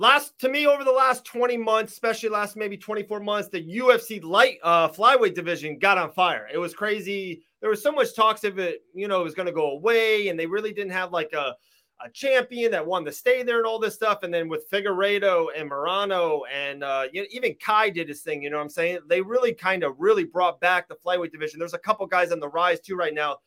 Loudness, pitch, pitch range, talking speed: -24 LUFS, 200 Hz, 175-230 Hz, 250 wpm